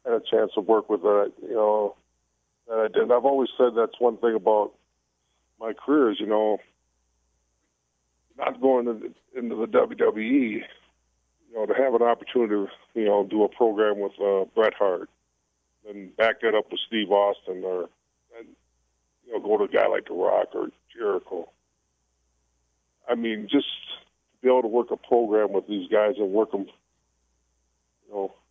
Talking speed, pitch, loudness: 180 wpm, 100 Hz, -24 LUFS